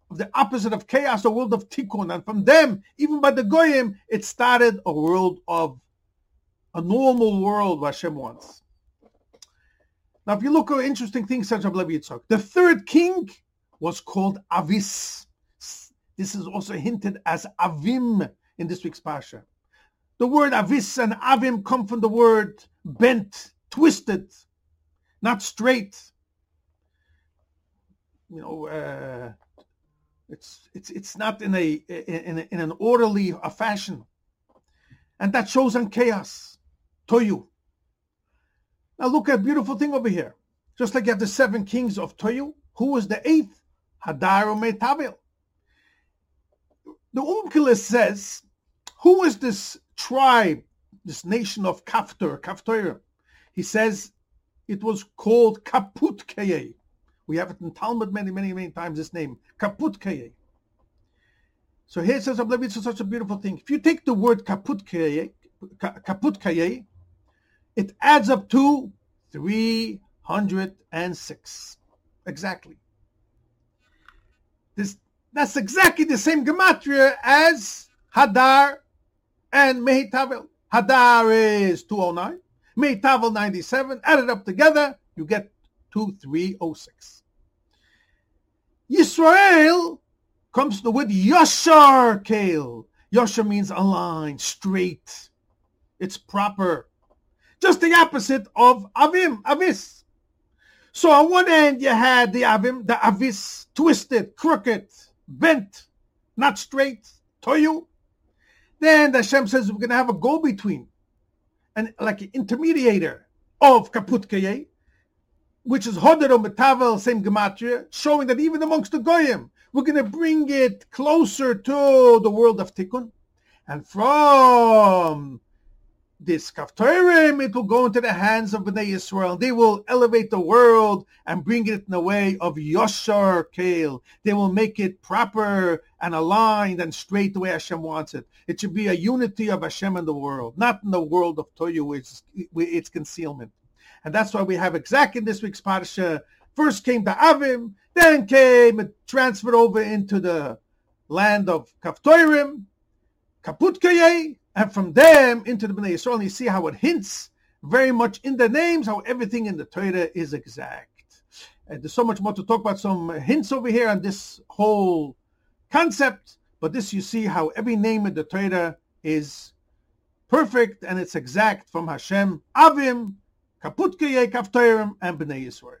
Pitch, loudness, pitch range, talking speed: 215 Hz, -20 LUFS, 175-255 Hz, 135 wpm